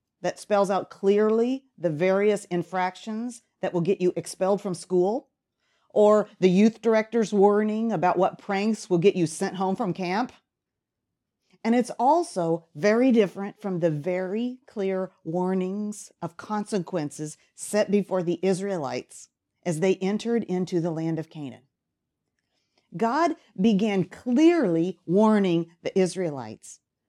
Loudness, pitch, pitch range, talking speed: -25 LUFS, 195 Hz, 180-215 Hz, 130 wpm